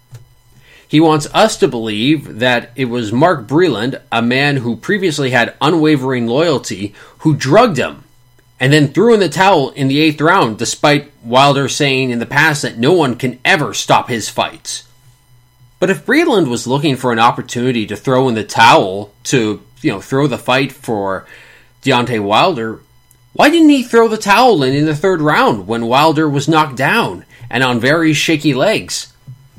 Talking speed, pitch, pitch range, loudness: 175 wpm, 130 Hz, 120-155 Hz, -13 LUFS